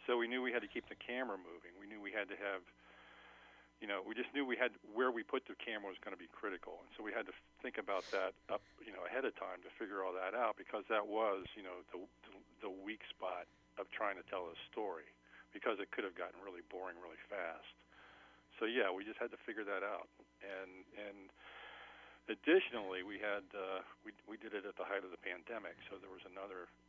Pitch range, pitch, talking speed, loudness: 95-125 Hz, 105 Hz, 235 wpm, -43 LUFS